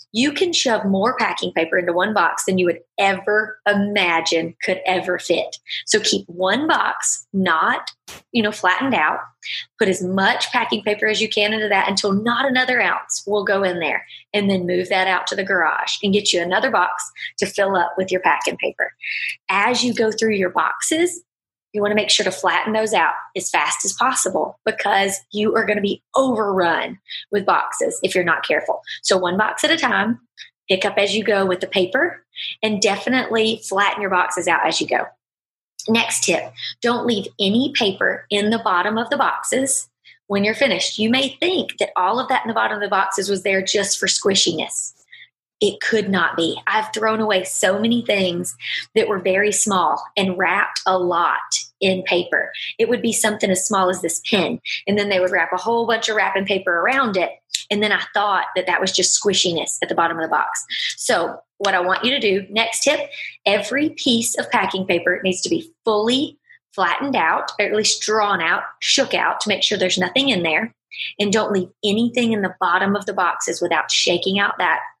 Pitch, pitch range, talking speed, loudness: 205 Hz, 190-230 Hz, 205 wpm, -19 LUFS